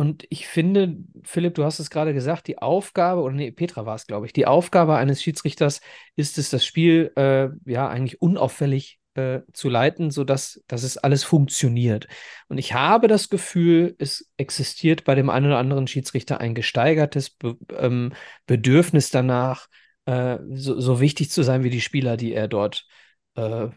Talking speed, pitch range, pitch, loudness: 170 wpm, 130-165 Hz, 140 Hz, -21 LUFS